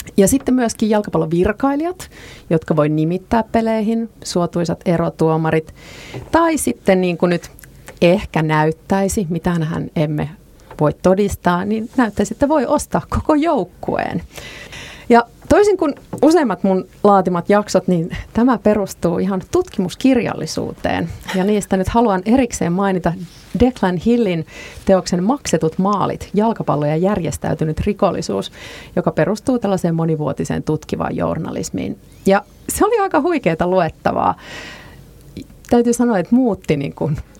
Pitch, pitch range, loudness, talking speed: 195 Hz, 170-235 Hz, -17 LUFS, 115 wpm